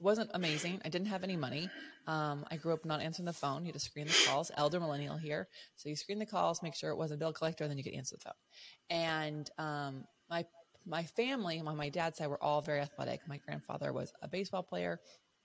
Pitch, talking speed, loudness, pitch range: 155 Hz, 235 wpm, -38 LUFS, 145-170 Hz